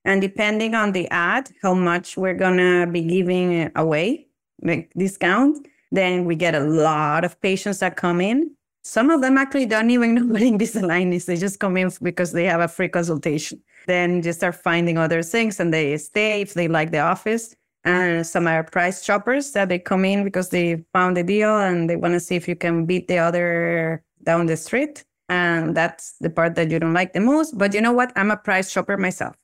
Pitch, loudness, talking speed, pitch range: 180 Hz, -20 LUFS, 215 wpm, 170-205 Hz